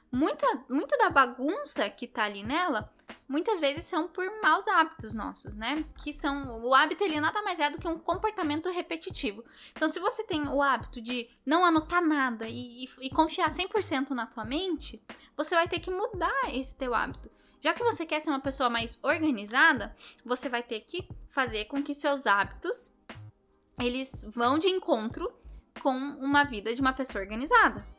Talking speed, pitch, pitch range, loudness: 180 wpm, 290 Hz, 255-335 Hz, -29 LUFS